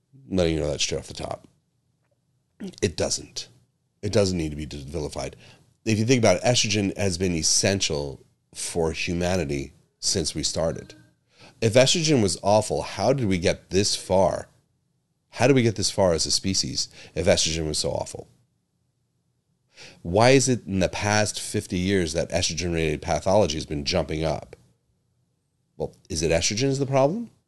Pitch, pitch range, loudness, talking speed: 95 Hz, 80-115 Hz, -23 LUFS, 165 wpm